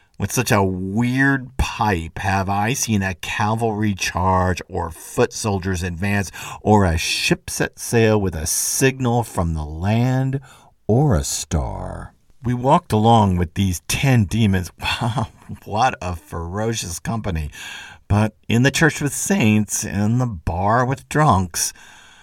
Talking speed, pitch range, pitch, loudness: 140 wpm, 95-120 Hz, 105 Hz, -20 LUFS